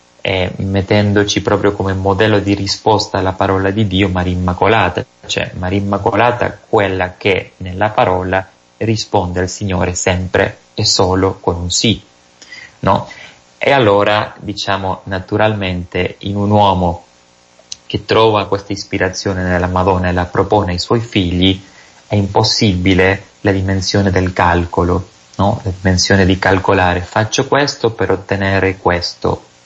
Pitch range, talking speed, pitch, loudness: 90-100 Hz, 125 wpm, 95 Hz, -14 LUFS